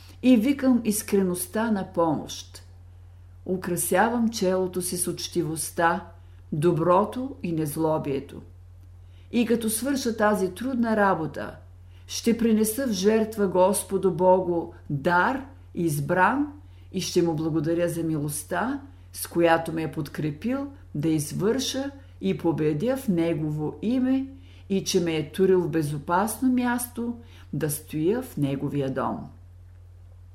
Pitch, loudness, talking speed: 170 Hz, -25 LUFS, 115 wpm